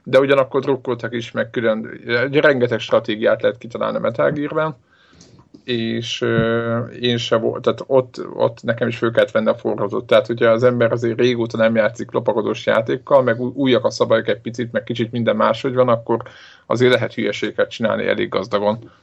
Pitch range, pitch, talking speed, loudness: 115-130 Hz, 120 Hz, 175 wpm, -18 LUFS